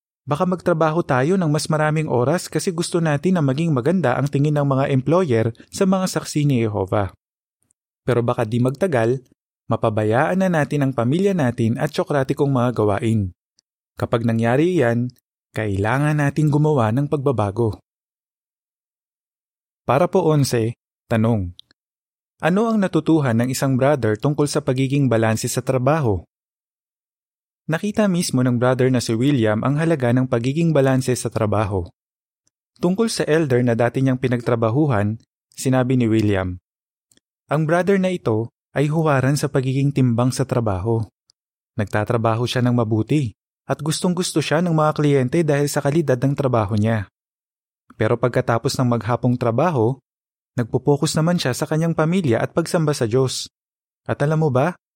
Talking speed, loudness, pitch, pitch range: 145 wpm, -20 LUFS, 130 Hz, 115-155 Hz